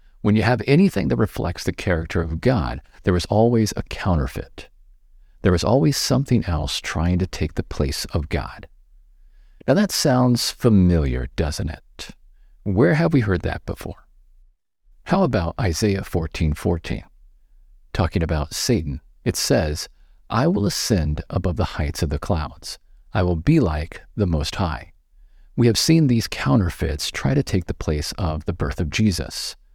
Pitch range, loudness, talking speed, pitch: 80-110 Hz, -21 LUFS, 160 wpm, 90 Hz